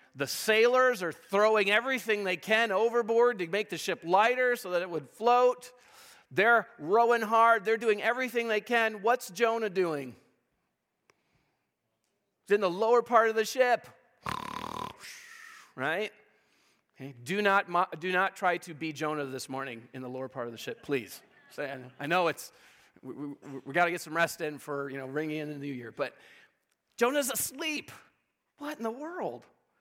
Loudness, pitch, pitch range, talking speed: -29 LUFS, 205 Hz, 155-235 Hz, 170 wpm